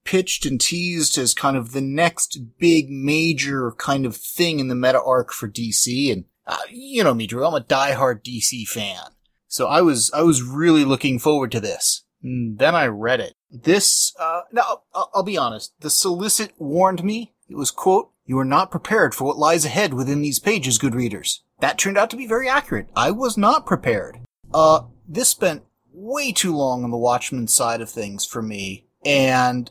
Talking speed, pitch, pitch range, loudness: 200 wpm, 145 Hz, 125-180 Hz, -19 LUFS